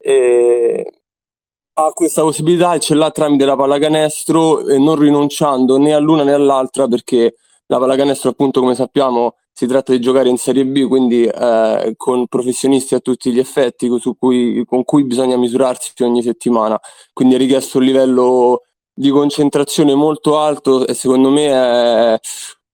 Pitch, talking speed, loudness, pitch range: 130 Hz, 155 wpm, -13 LUFS, 125-145 Hz